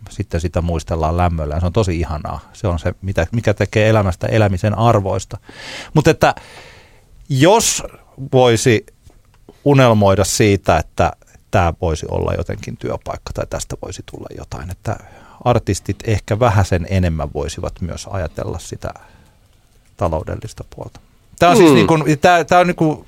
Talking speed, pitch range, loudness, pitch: 145 wpm, 90-115 Hz, -16 LUFS, 100 Hz